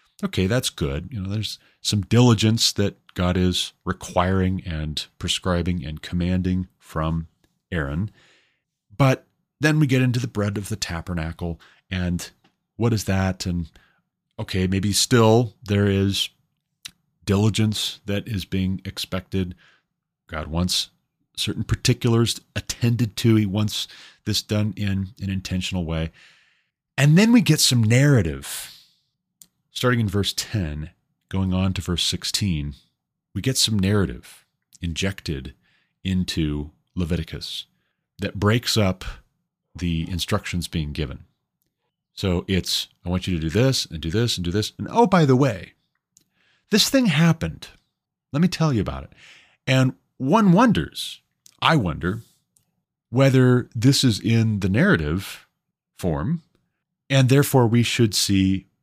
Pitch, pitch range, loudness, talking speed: 100 Hz, 90-125 Hz, -22 LUFS, 135 wpm